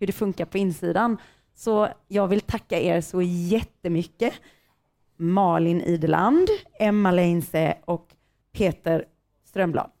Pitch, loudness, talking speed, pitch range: 180 Hz, -24 LUFS, 115 wpm, 170-210 Hz